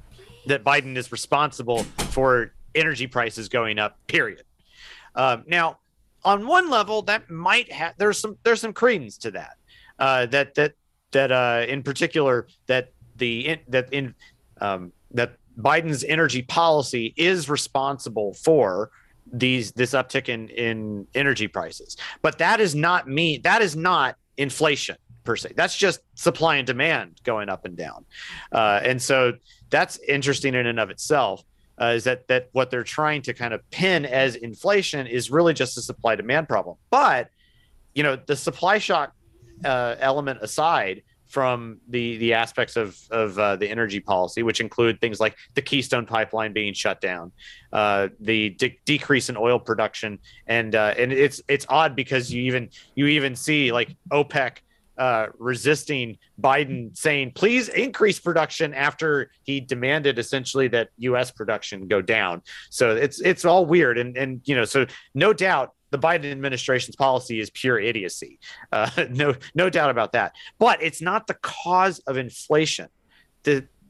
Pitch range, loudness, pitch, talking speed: 120-155 Hz, -22 LUFS, 130 Hz, 160 wpm